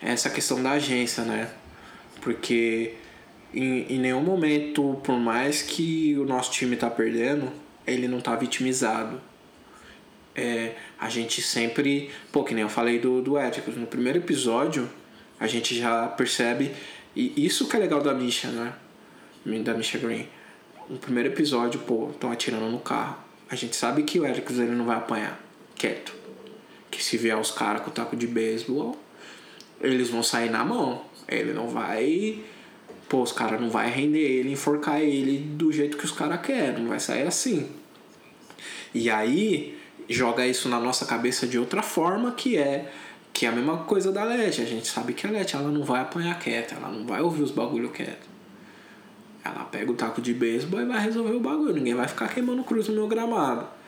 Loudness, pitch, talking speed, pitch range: -26 LUFS, 130 Hz, 185 wpm, 115-150 Hz